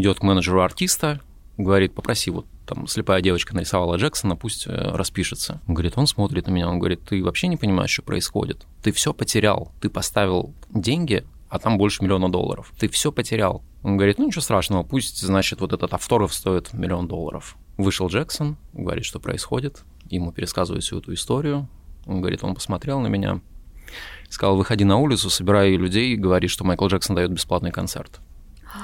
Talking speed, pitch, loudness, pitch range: 175 wpm, 95 Hz, -22 LUFS, 90-115 Hz